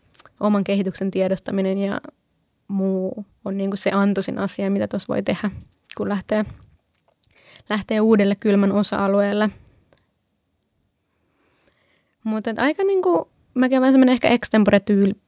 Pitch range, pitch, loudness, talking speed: 195-220 Hz, 205 Hz, -20 LUFS, 115 wpm